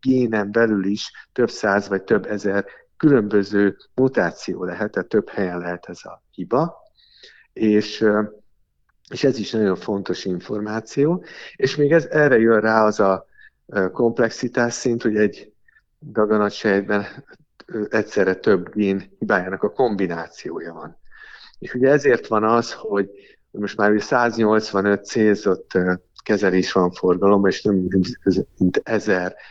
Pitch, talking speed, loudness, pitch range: 105 Hz, 125 wpm, -20 LUFS, 100-115 Hz